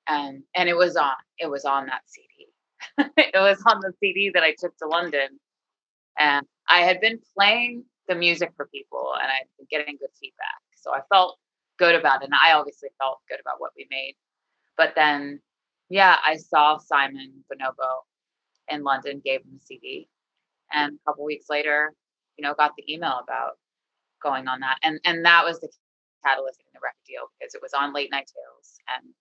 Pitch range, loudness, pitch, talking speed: 140-190 Hz, -22 LUFS, 150 Hz, 195 wpm